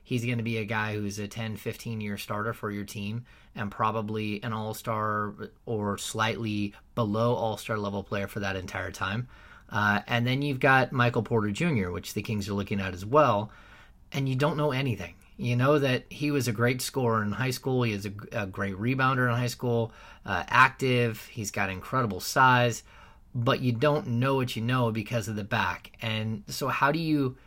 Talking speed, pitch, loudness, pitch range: 205 wpm, 115 Hz, -28 LUFS, 105-125 Hz